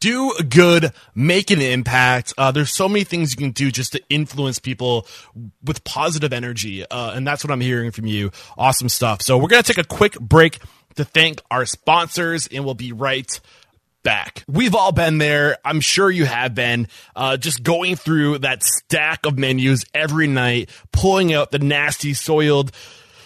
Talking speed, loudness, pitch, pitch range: 185 wpm, -17 LUFS, 140 Hz, 125-160 Hz